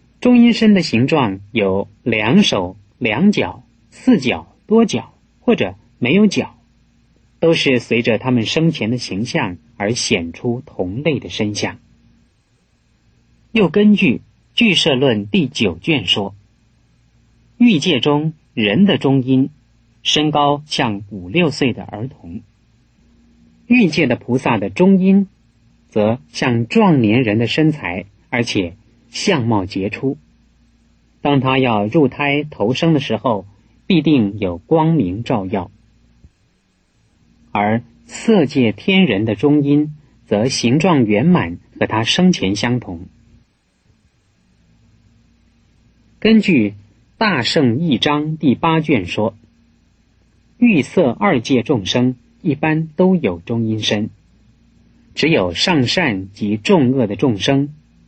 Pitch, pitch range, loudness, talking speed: 125 Hz, 105-155 Hz, -16 LUFS, 160 characters per minute